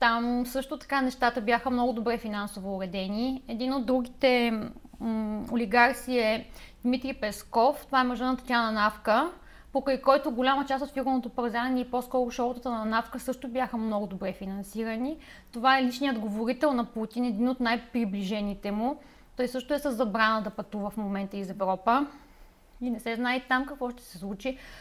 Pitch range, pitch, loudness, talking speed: 220-260 Hz, 245 Hz, -29 LUFS, 165 wpm